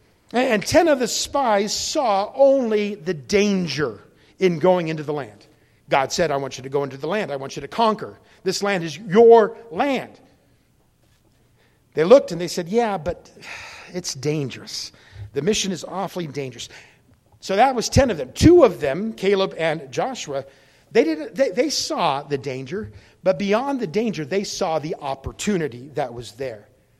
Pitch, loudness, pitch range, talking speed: 180 Hz, -21 LUFS, 140-210 Hz, 175 wpm